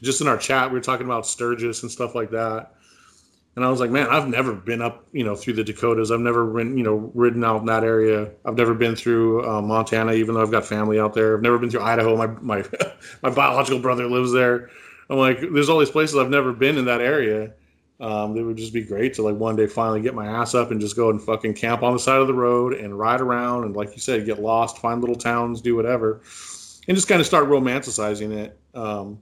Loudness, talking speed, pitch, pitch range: -21 LUFS, 255 wpm, 115 Hz, 110-125 Hz